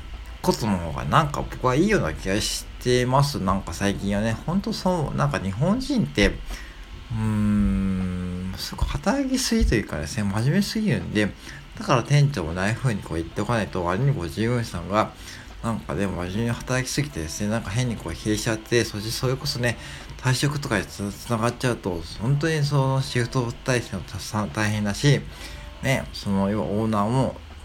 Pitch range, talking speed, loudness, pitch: 95-130 Hz, 380 characters per minute, -24 LUFS, 110 Hz